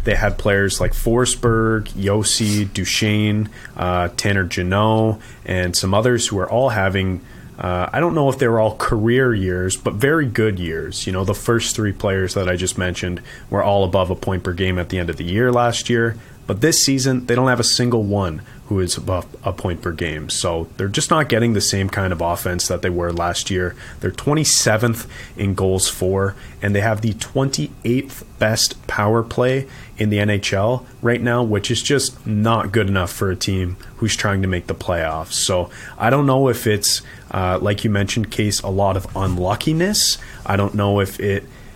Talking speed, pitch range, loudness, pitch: 200 wpm, 95-120 Hz, -19 LUFS, 105 Hz